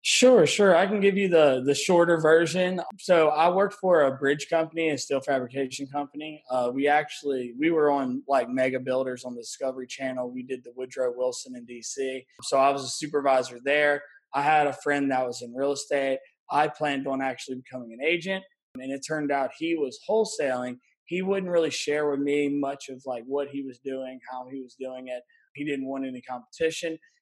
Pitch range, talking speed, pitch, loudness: 130-160 Hz, 205 wpm, 140 Hz, -26 LUFS